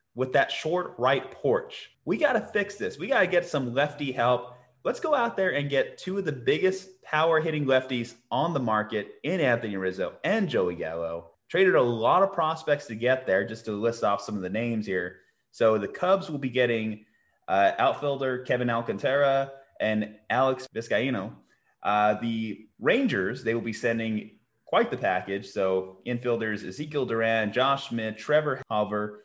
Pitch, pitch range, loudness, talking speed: 120 Hz, 110-145 Hz, -27 LUFS, 180 wpm